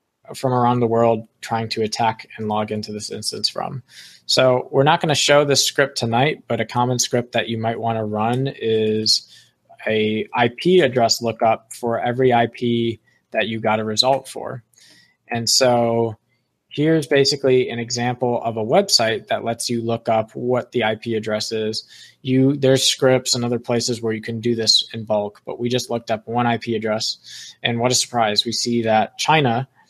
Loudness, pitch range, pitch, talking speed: -19 LUFS, 110-125 Hz, 115 Hz, 190 wpm